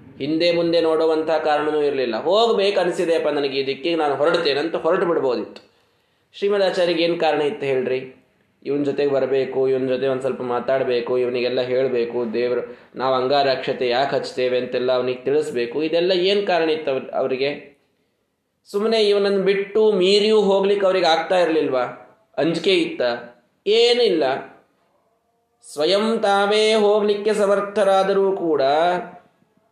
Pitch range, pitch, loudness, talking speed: 130-200 Hz, 160 Hz, -20 LUFS, 115 wpm